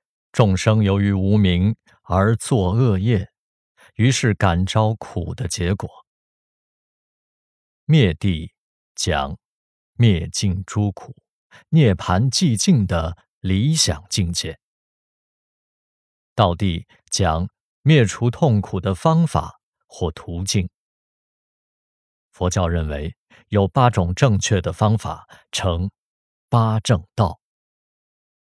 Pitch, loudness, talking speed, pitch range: 100 Hz, -20 LUFS, 135 characters per minute, 90-115 Hz